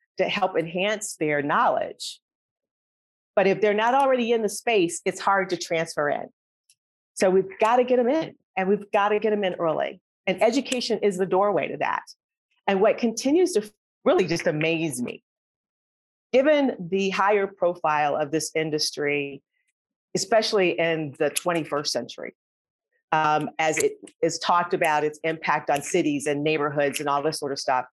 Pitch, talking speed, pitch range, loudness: 185 Hz, 170 wpm, 155-215 Hz, -24 LUFS